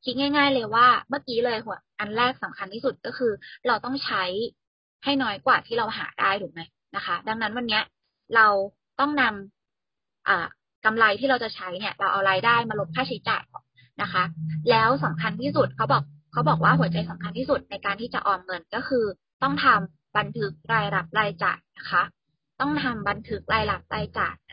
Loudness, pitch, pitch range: -24 LUFS, 215 Hz, 185-250 Hz